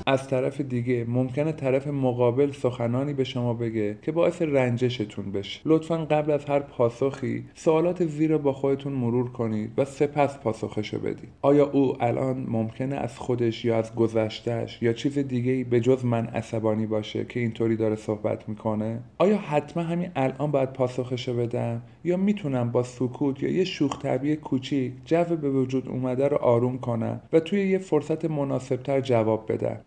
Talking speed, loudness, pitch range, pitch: 165 wpm, -26 LUFS, 115-145 Hz, 130 Hz